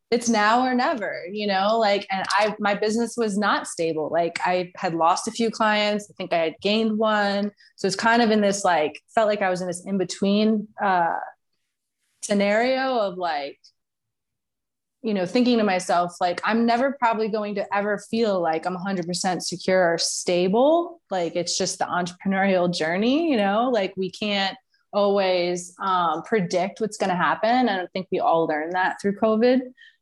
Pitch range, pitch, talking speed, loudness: 180-225 Hz, 200 Hz, 185 wpm, -23 LUFS